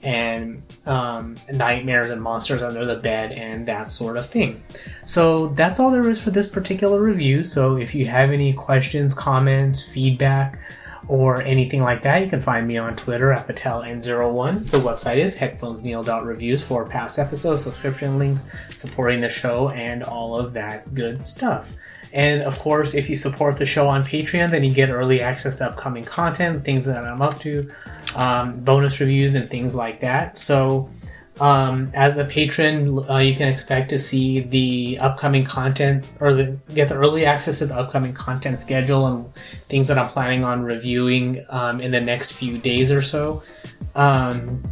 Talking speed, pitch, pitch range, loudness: 175 wpm, 135 Hz, 125-140 Hz, -20 LUFS